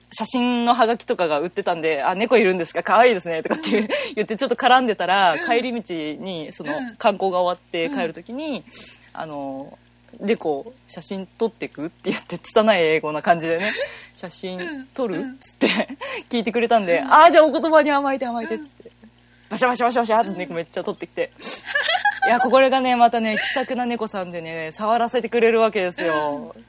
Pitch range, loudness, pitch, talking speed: 175-250 Hz, -20 LUFS, 225 Hz, 395 characters per minute